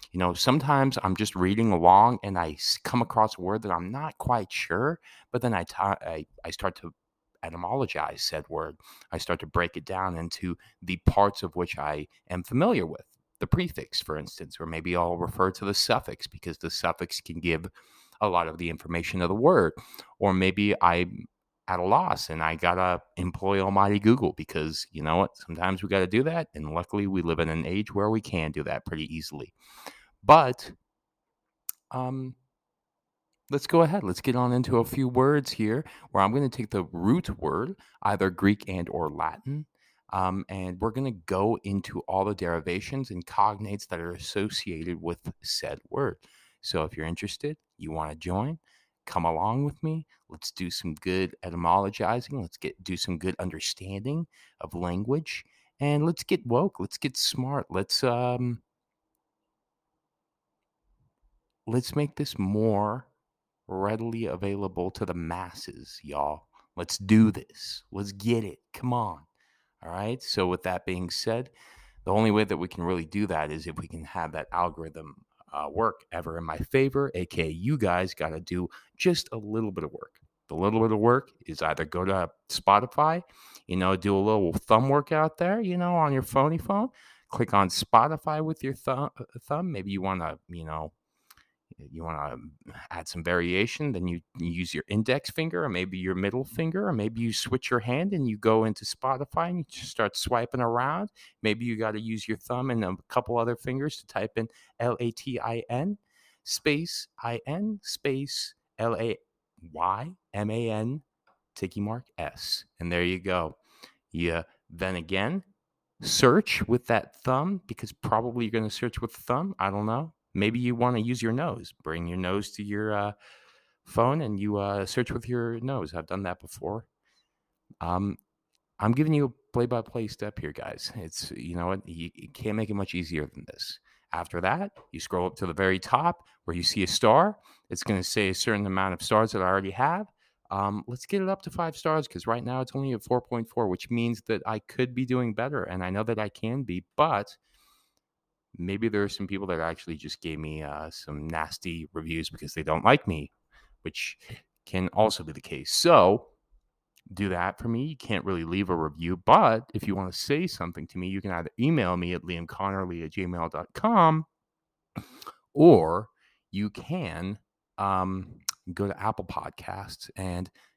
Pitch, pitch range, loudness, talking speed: 100 Hz, 90-125 Hz, -28 LUFS, 185 wpm